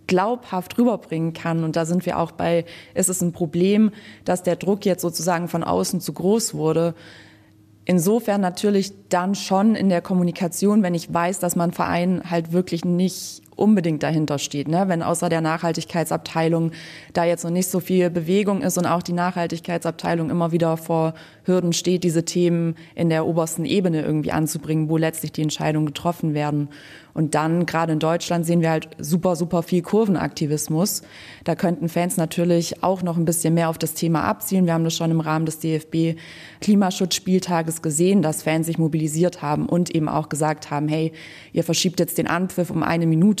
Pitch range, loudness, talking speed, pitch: 160-180 Hz, -21 LUFS, 180 wpm, 170 Hz